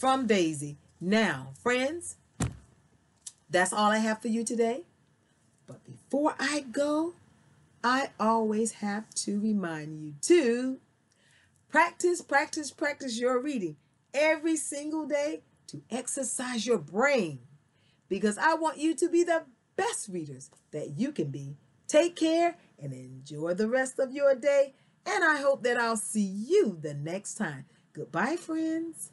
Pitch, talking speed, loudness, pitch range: 240 Hz, 140 wpm, -29 LUFS, 180-295 Hz